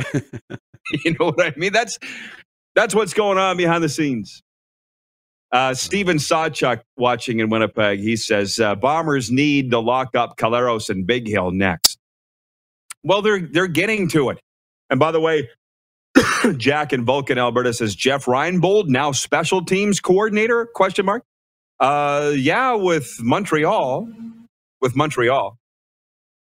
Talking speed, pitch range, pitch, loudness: 140 wpm, 120-180 Hz, 145 Hz, -19 LUFS